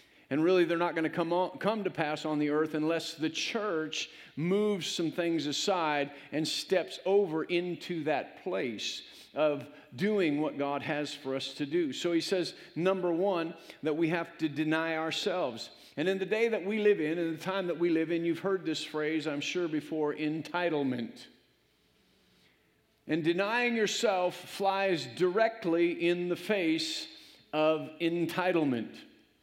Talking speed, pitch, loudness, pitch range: 165 wpm, 165 Hz, -31 LUFS, 155-190 Hz